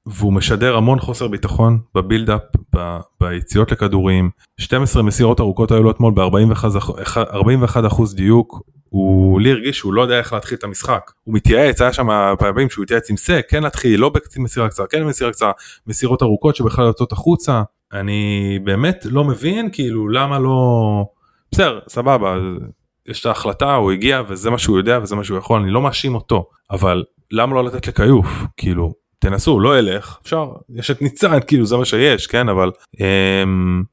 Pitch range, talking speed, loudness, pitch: 100-125 Hz, 170 wpm, -16 LUFS, 110 Hz